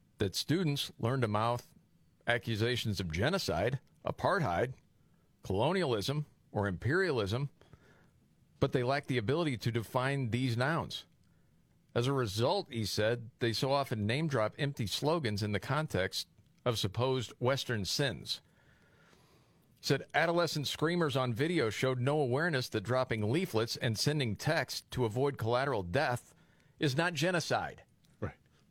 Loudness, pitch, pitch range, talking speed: -33 LUFS, 130 Hz, 115-145 Hz, 125 wpm